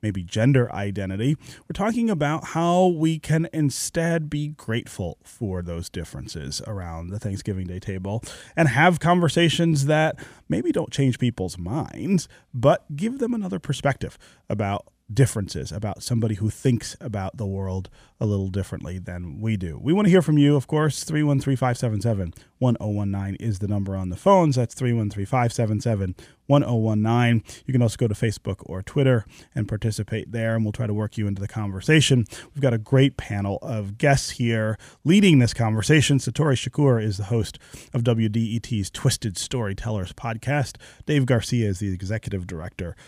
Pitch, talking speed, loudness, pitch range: 115 Hz, 160 wpm, -23 LUFS, 100-140 Hz